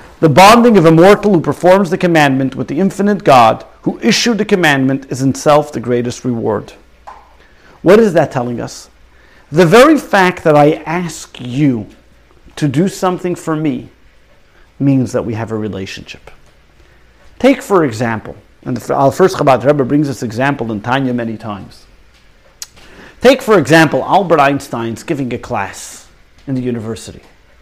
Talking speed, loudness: 155 wpm, -12 LUFS